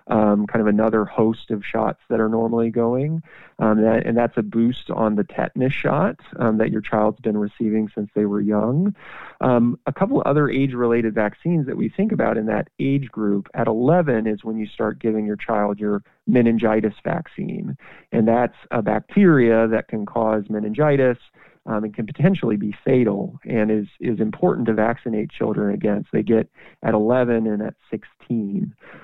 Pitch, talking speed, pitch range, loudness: 110 Hz, 185 wpm, 110-120 Hz, -21 LUFS